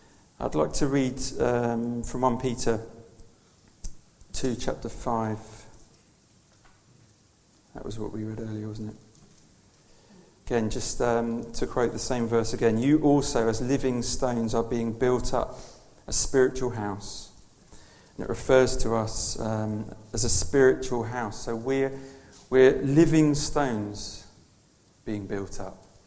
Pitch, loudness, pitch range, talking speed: 115 Hz, -26 LUFS, 110-130 Hz, 135 wpm